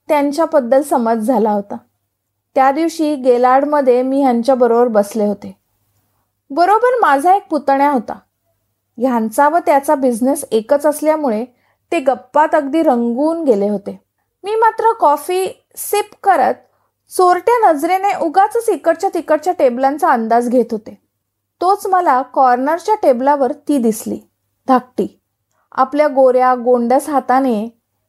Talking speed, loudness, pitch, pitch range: 120 wpm, -14 LUFS, 275 Hz, 245-330 Hz